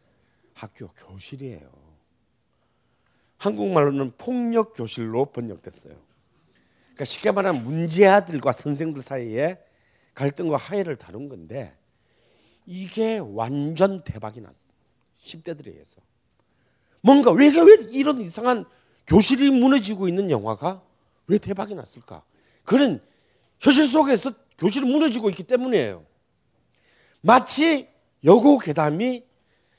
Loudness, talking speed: -20 LUFS, 255 characters per minute